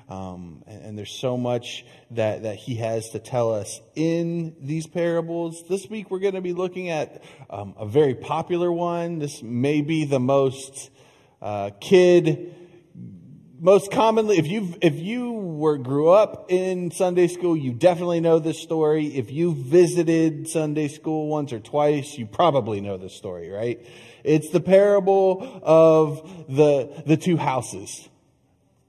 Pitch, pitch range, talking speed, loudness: 155 Hz, 130-175 Hz, 155 wpm, -22 LUFS